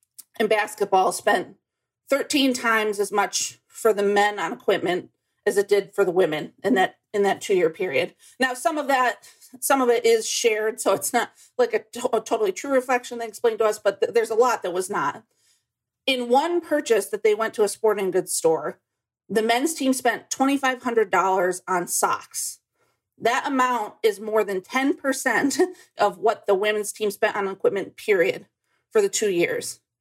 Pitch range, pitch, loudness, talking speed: 205-280 Hz, 230 Hz, -23 LUFS, 185 wpm